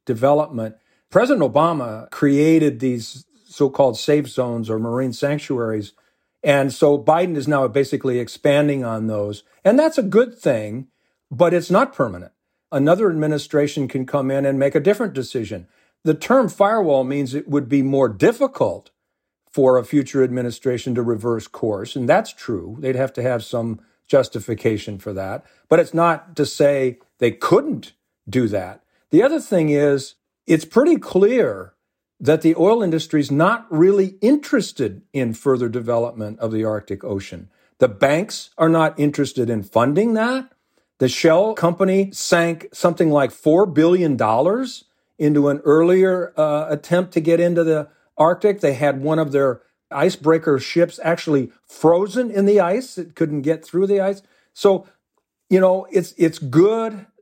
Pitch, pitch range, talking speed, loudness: 150 Hz, 130-180 Hz, 155 wpm, -18 LUFS